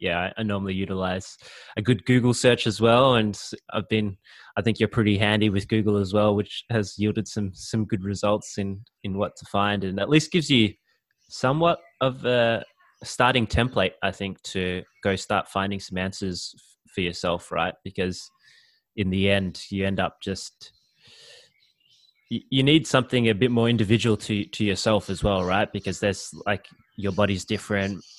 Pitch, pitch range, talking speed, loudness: 105 Hz, 95-115 Hz, 175 wpm, -24 LUFS